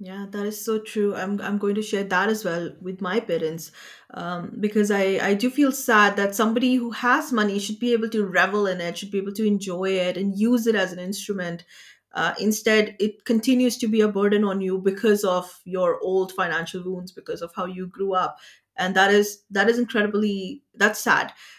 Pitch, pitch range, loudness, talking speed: 205 Hz, 185-215 Hz, -23 LUFS, 215 wpm